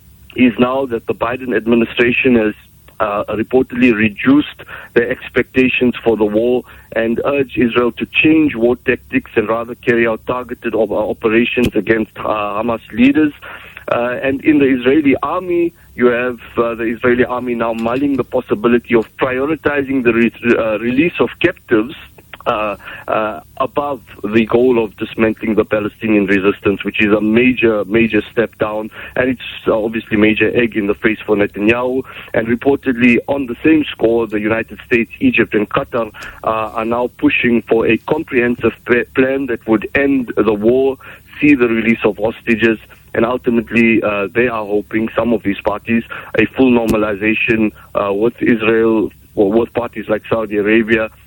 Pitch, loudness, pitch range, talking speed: 115 Hz, -15 LUFS, 110-125 Hz, 165 wpm